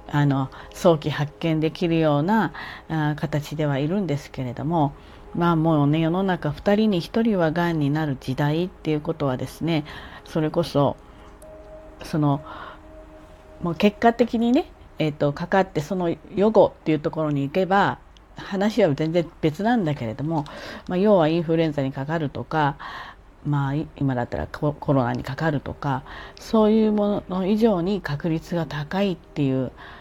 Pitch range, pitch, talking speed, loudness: 140-175 Hz, 155 Hz, 305 characters per minute, -23 LUFS